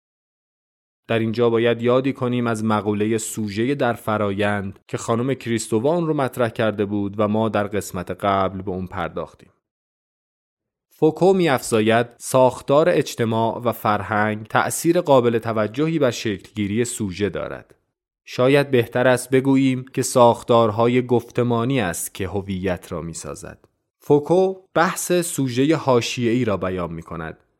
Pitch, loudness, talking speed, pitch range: 115 Hz, -20 LUFS, 130 wpm, 105-130 Hz